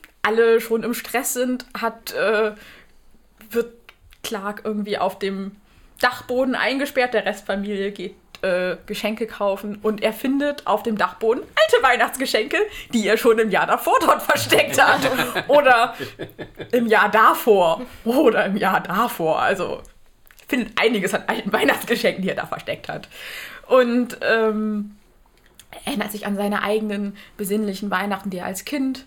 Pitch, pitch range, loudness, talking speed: 220 Hz, 205-245 Hz, -20 LUFS, 145 wpm